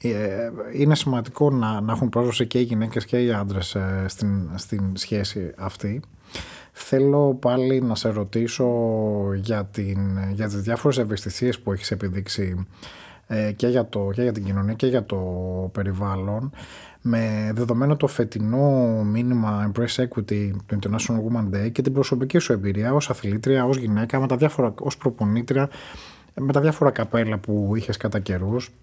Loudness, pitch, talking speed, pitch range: -23 LUFS, 110 Hz, 155 wpm, 100-125 Hz